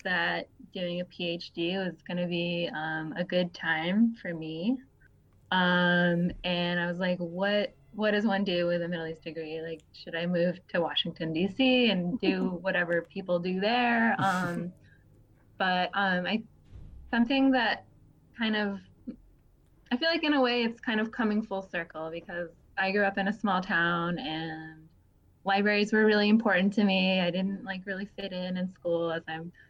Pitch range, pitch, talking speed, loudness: 170-205 Hz, 180 Hz, 175 wpm, -29 LUFS